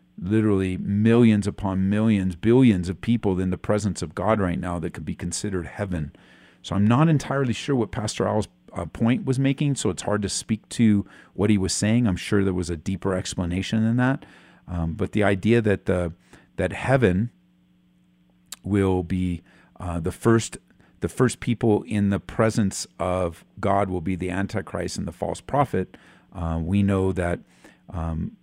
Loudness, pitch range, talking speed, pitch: -24 LUFS, 90-110 Hz, 175 wpm, 100 Hz